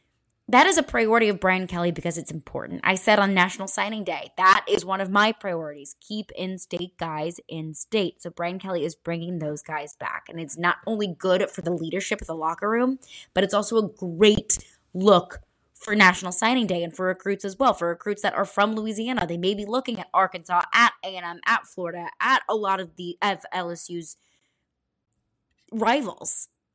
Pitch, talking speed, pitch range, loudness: 185 Hz, 195 wpm, 170-210 Hz, -23 LUFS